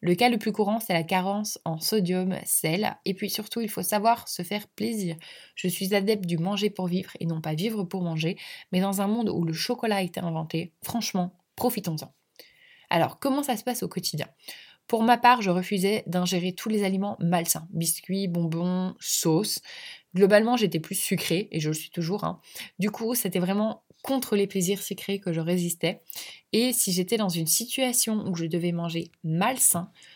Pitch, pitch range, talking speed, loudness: 195 Hz, 175-215 Hz, 195 wpm, -26 LUFS